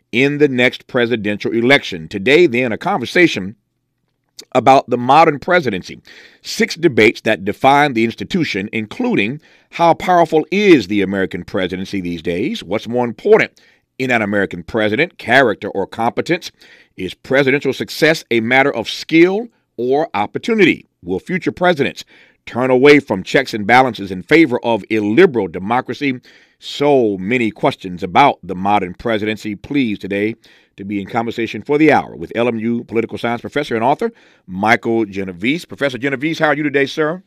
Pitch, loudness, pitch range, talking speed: 120 Hz, -15 LUFS, 105-145 Hz, 150 wpm